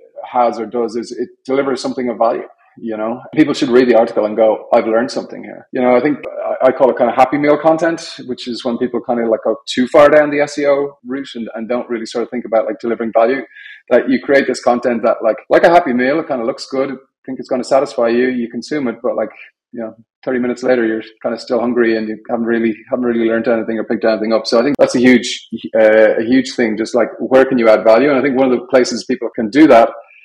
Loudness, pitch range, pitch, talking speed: -14 LUFS, 115-130 Hz, 120 Hz, 275 wpm